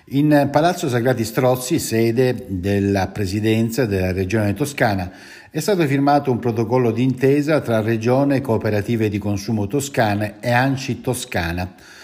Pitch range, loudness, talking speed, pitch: 105-135 Hz, -19 LUFS, 125 wpm, 120 Hz